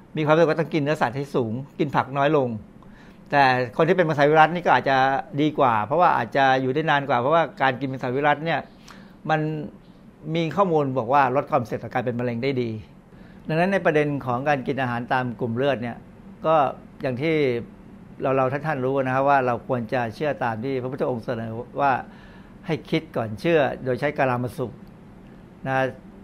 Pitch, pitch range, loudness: 140 Hz, 130-160 Hz, -23 LUFS